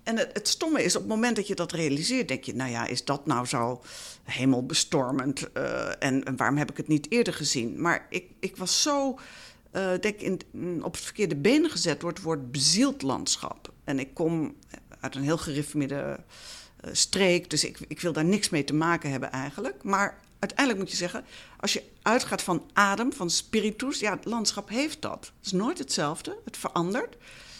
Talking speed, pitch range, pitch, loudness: 200 wpm, 145-210 Hz, 175 Hz, -27 LUFS